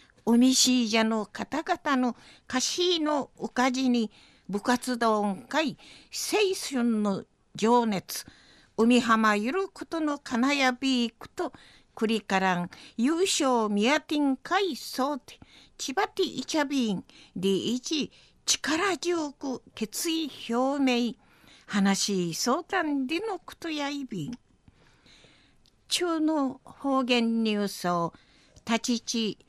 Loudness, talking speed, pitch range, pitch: -27 LUFS, 185 characters per minute, 225-300 Hz, 255 Hz